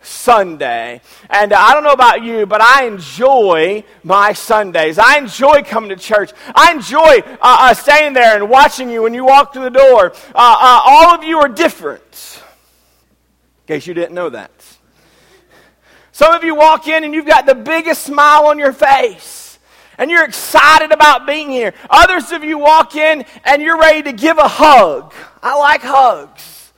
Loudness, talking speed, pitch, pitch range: -9 LUFS, 180 wpm, 285 Hz, 220-310 Hz